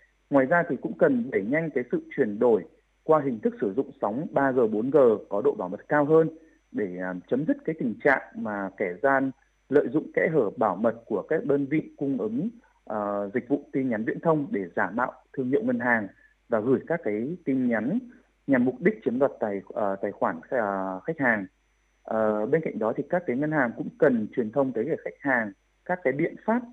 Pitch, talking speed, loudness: 150 Hz, 220 wpm, -26 LUFS